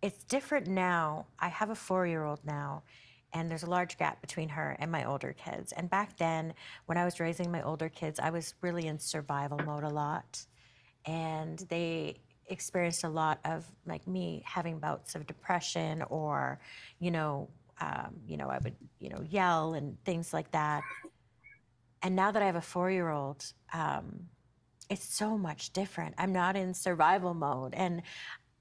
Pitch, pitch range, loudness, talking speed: 165 Hz, 150-180 Hz, -35 LUFS, 170 wpm